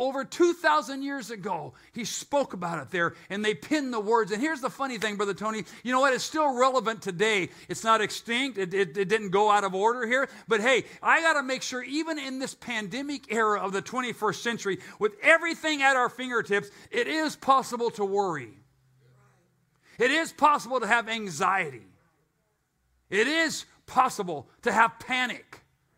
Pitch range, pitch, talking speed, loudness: 205-270 Hz, 230 Hz, 180 wpm, -26 LUFS